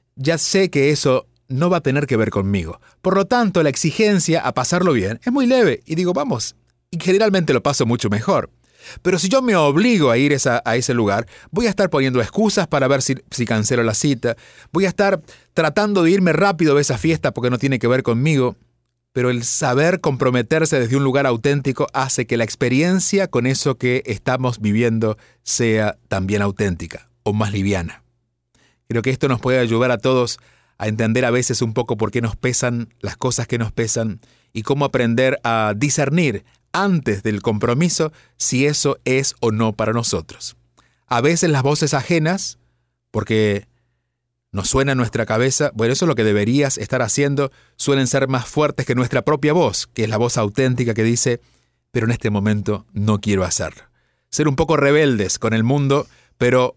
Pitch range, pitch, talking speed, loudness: 115-145 Hz, 125 Hz, 190 wpm, -18 LUFS